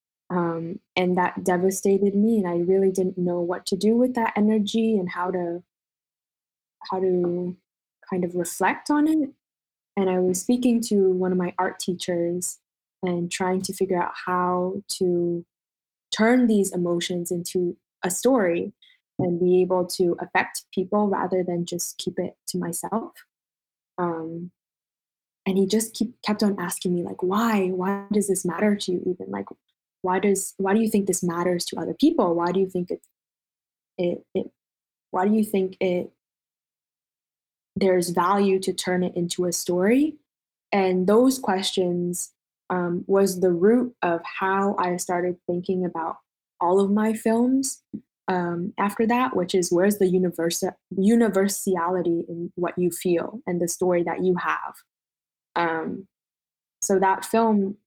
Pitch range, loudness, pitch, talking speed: 175-200 Hz, -24 LUFS, 185 Hz, 160 wpm